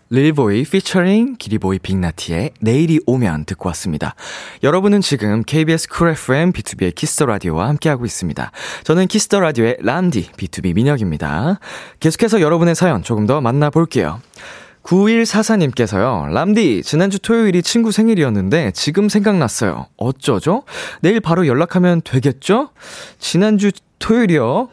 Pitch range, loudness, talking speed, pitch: 125-200 Hz, -16 LUFS, 340 characters per minute, 160 Hz